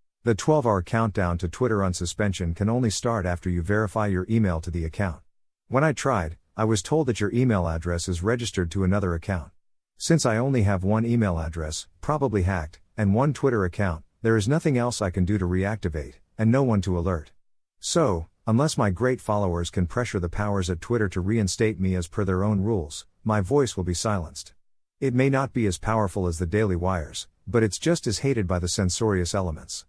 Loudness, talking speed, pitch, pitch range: -25 LUFS, 210 wpm, 100 Hz, 90-115 Hz